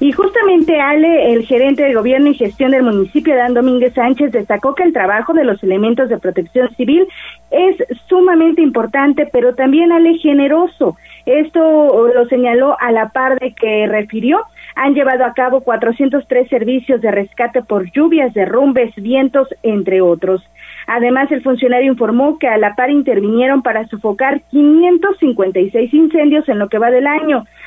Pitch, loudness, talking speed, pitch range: 260 Hz, -12 LUFS, 160 wpm, 230-295 Hz